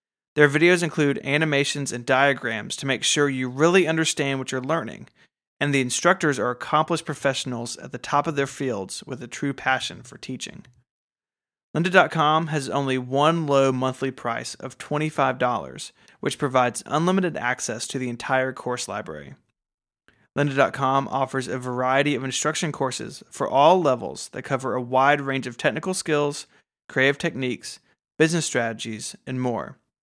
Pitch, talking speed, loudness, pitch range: 135 Hz, 150 wpm, -23 LUFS, 130-150 Hz